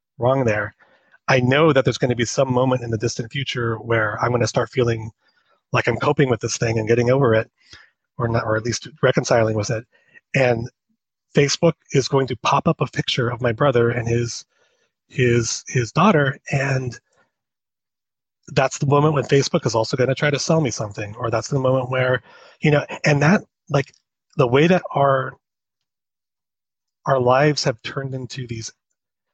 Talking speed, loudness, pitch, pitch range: 185 wpm, -20 LUFS, 130 Hz, 120-145 Hz